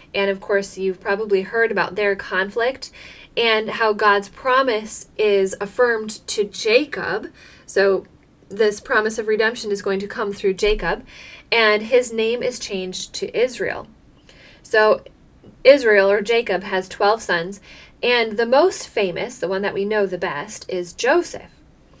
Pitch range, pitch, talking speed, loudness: 195-230 Hz, 210 Hz, 150 wpm, -19 LUFS